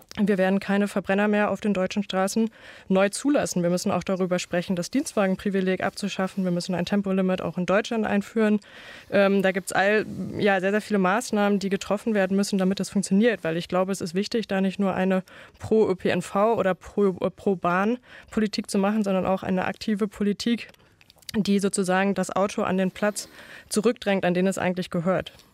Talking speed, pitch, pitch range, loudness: 180 wpm, 195 Hz, 185-210 Hz, -24 LUFS